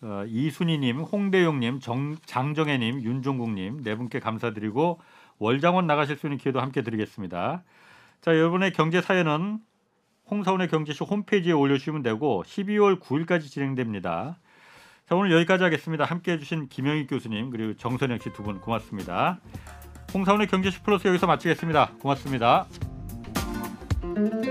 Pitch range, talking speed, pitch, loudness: 120-180 Hz, 350 characters per minute, 150 Hz, -26 LUFS